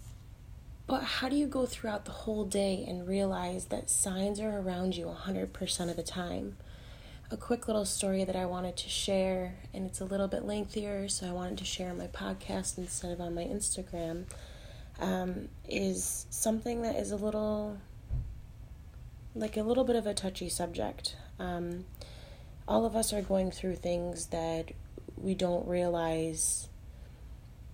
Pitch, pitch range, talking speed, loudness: 180 Hz, 145-205 Hz, 160 wpm, -34 LUFS